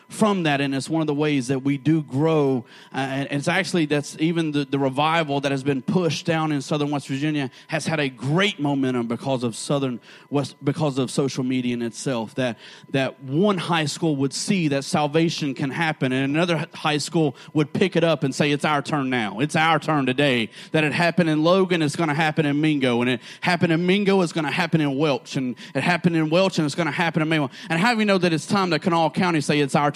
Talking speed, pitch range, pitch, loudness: 245 wpm, 140-170 Hz, 155 Hz, -22 LUFS